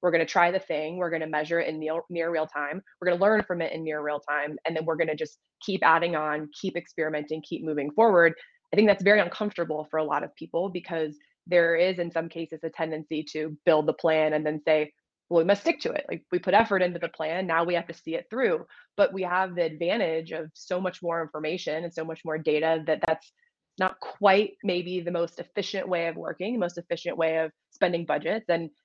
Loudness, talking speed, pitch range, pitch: -27 LUFS, 235 wpm, 155-180 Hz, 165 Hz